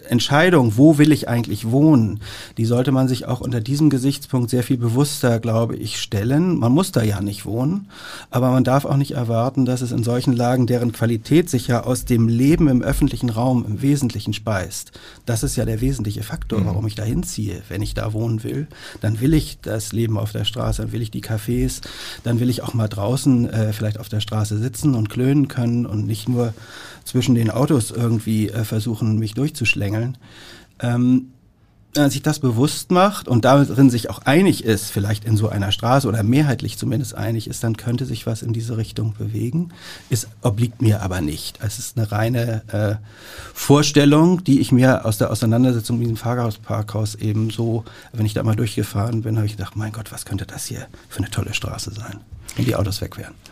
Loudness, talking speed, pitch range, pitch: -20 LUFS, 205 wpm, 110-130 Hz, 115 Hz